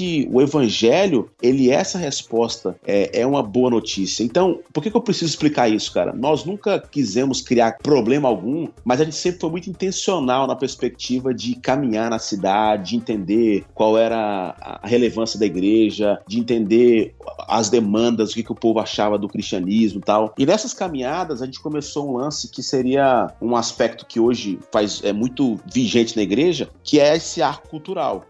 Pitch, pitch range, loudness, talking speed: 120 Hz, 110-145 Hz, -19 LUFS, 180 wpm